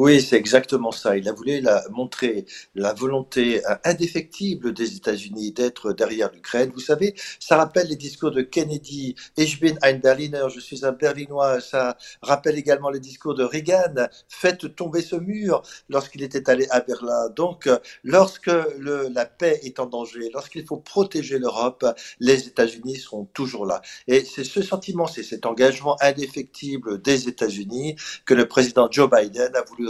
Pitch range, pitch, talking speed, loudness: 125-155 Hz, 140 Hz, 165 wpm, -22 LUFS